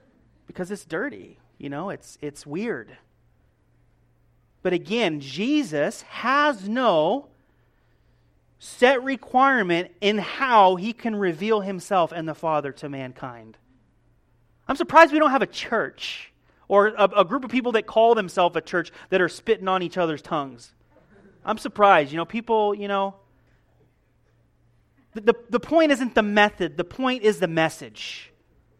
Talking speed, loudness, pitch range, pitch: 145 wpm, -22 LUFS, 150-225 Hz, 195 Hz